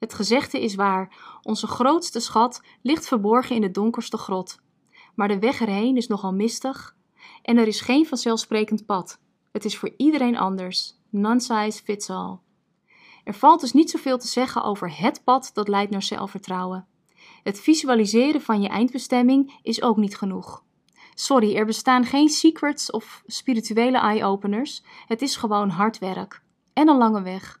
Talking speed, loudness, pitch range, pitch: 165 wpm, -22 LUFS, 205-255 Hz, 225 Hz